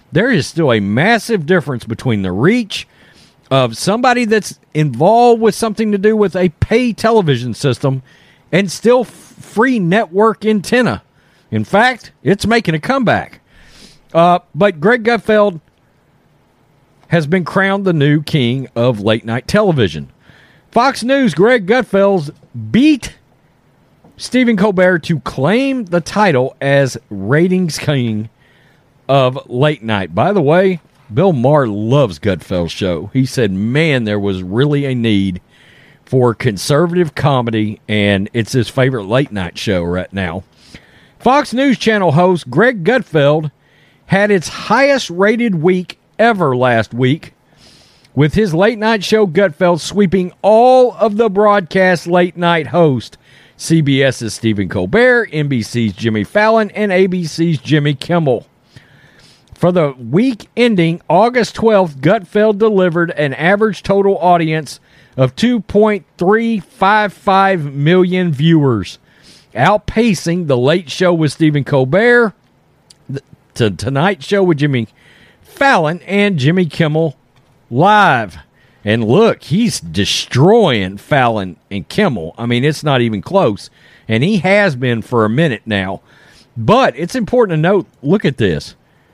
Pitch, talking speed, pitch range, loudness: 165 Hz, 130 wpm, 130-205 Hz, -13 LUFS